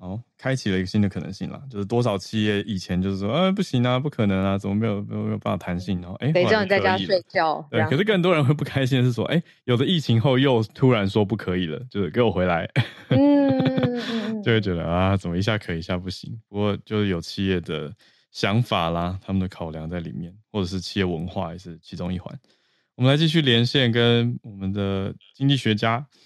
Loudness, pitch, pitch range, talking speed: -23 LUFS, 110 Hz, 95-130 Hz, 340 characters per minute